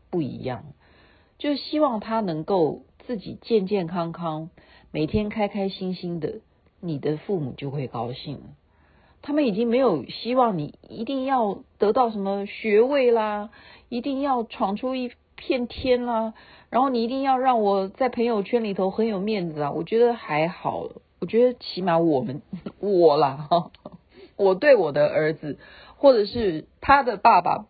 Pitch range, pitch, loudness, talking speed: 165-240 Hz, 205 Hz, -23 LUFS, 225 characters per minute